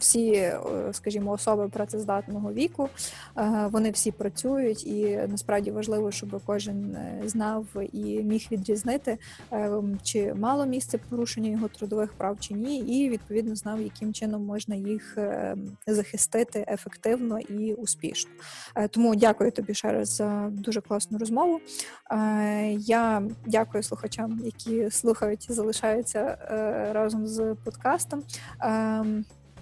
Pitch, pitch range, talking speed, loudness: 215 Hz, 205-225 Hz, 115 wpm, -28 LUFS